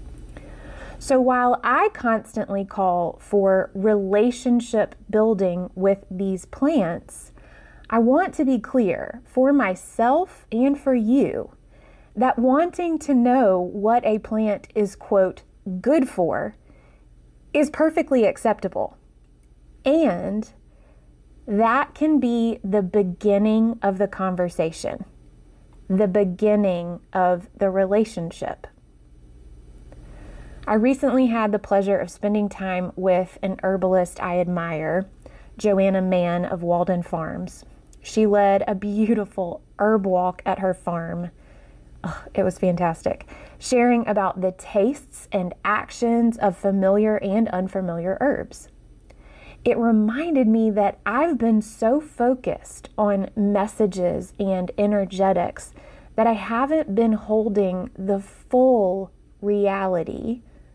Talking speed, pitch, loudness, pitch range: 110 wpm, 205 Hz, -22 LUFS, 185-235 Hz